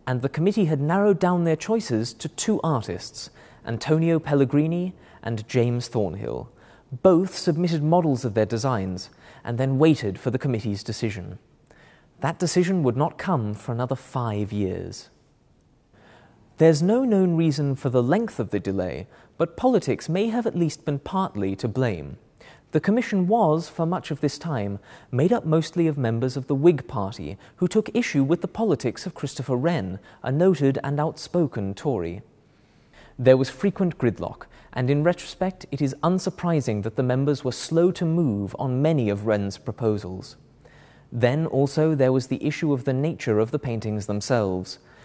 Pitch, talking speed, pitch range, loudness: 140 Hz, 165 wpm, 115-170 Hz, -24 LUFS